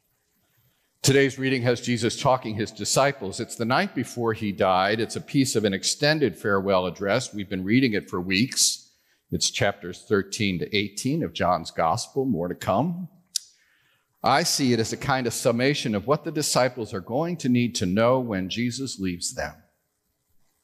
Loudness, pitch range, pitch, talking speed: -24 LUFS, 100-135 Hz, 115 Hz, 175 wpm